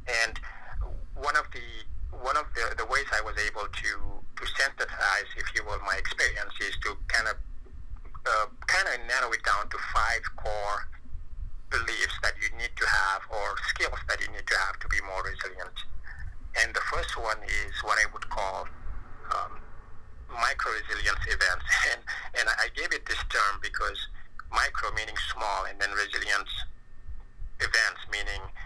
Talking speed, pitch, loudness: 165 wpm, 105 Hz, -29 LUFS